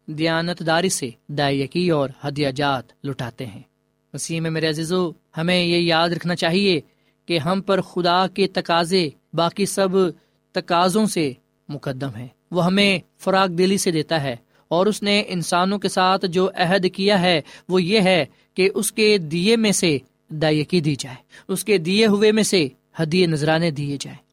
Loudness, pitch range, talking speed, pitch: -20 LUFS, 155-190 Hz, 170 wpm, 175 Hz